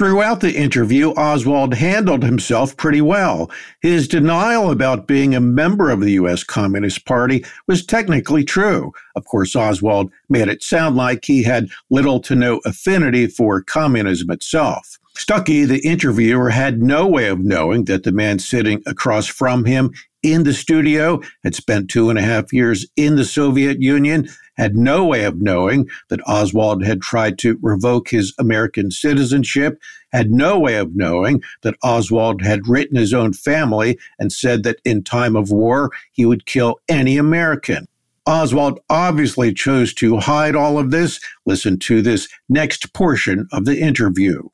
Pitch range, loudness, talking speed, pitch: 110-150 Hz, -16 LUFS, 165 wpm, 125 Hz